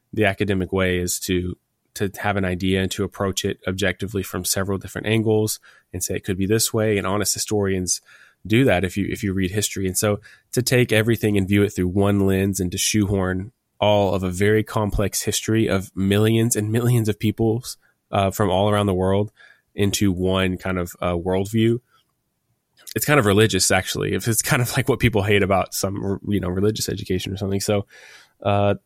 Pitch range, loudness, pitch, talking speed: 95-110 Hz, -21 LUFS, 100 Hz, 200 wpm